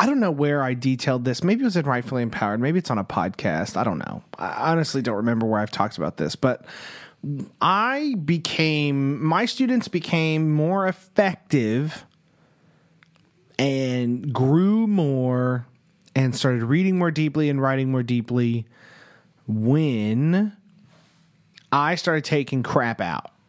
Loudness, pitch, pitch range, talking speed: -23 LUFS, 145 Hz, 125-170 Hz, 145 wpm